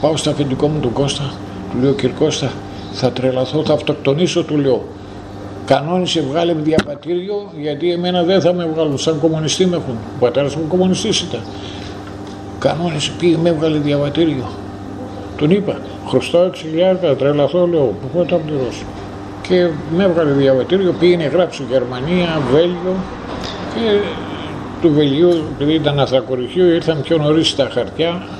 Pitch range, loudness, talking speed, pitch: 125-170 Hz, -16 LUFS, 145 wpm, 150 Hz